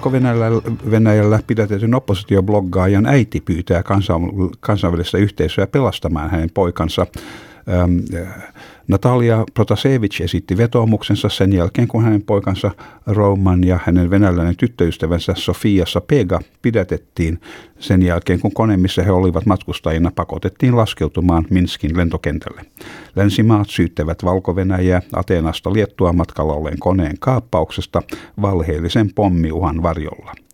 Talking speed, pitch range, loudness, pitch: 105 wpm, 85-105 Hz, -17 LUFS, 95 Hz